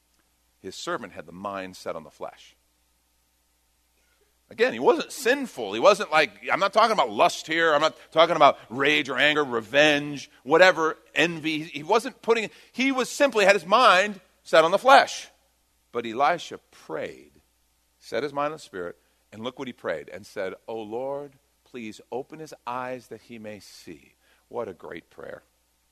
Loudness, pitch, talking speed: -23 LUFS, 140 Hz, 175 wpm